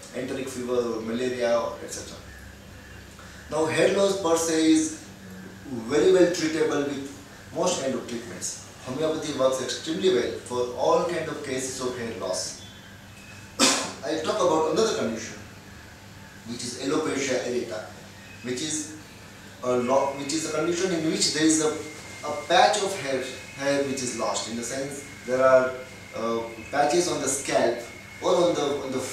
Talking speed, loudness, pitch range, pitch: 140 wpm, -25 LUFS, 100-150 Hz, 125 Hz